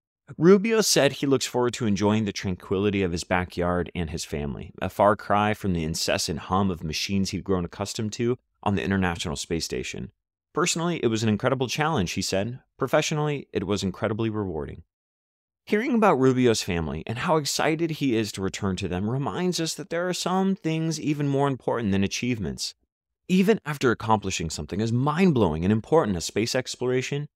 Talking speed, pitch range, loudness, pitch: 180 wpm, 95-145 Hz, -25 LUFS, 110 Hz